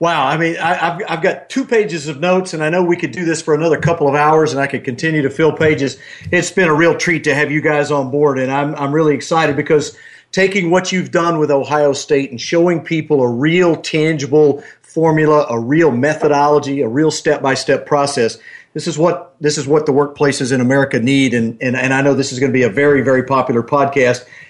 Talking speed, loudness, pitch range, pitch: 240 wpm, -14 LUFS, 140-165 Hz, 150 Hz